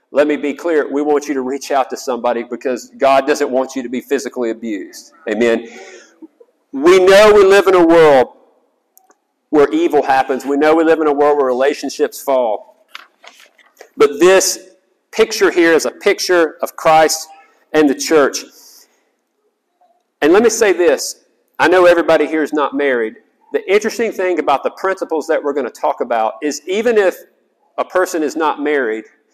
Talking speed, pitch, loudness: 175 wpm, 170 Hz, -14 LUFS